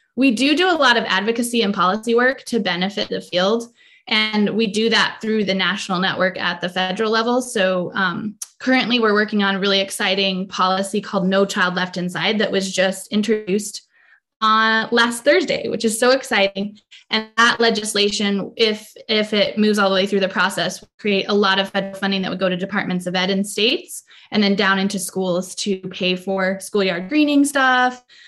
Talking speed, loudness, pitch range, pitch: 195 wpm, -18 LUFS, 190-225 Hz, 200 Hz